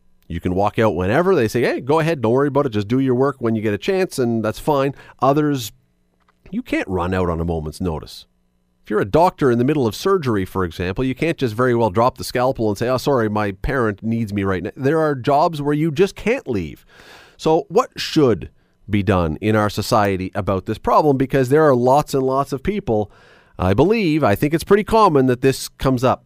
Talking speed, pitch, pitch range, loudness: 235 wpm, 120 Hz, 100-140 Hz, -18 LUFS